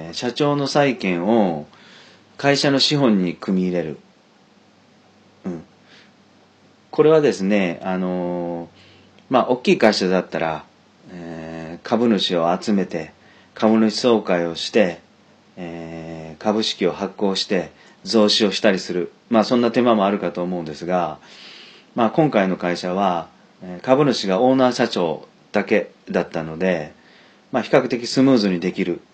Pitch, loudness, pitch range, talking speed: 95 Hz, -19 LUFS, 85-115 Hz, 255 characters per minute